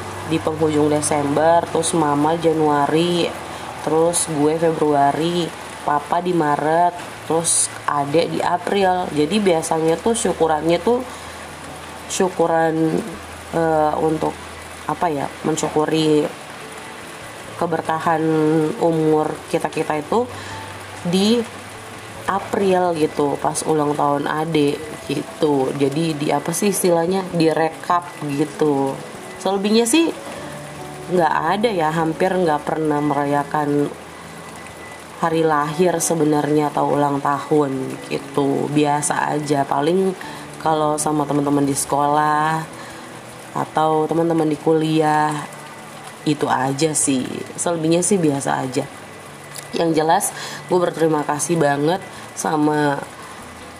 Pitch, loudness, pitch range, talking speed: 155 Hz, -19 LUFS, 145-165 Hz, 100 wpm